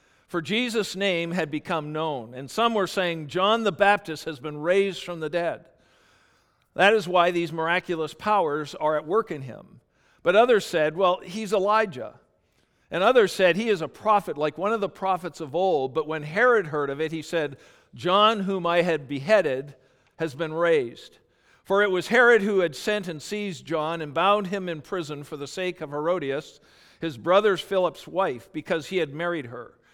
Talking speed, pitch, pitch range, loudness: 190 wpm, 175 Hz, 155-200 Hz, -24 LUFS